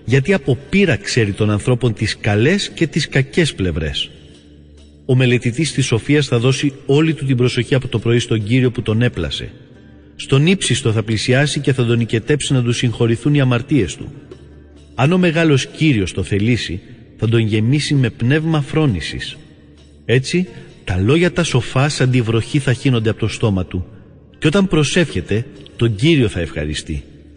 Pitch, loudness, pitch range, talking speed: 120 Hz, -16 LUFS, 100-145 Hz, 170 wpm